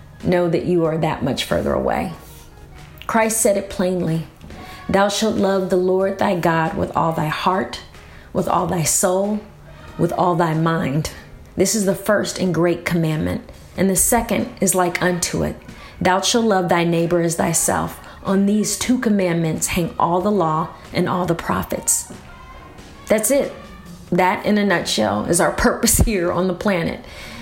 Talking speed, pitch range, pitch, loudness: 170 wpm, 160-195 Hz, 180 Hz, -19 LUFS